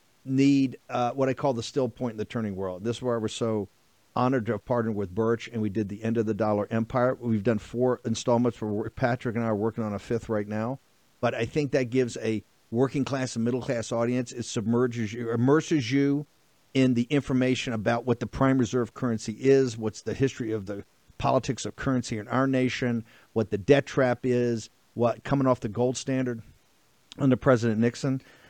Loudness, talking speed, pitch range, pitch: -27 LUFS, 210 wpm, 115-130 Hz, 120 Hz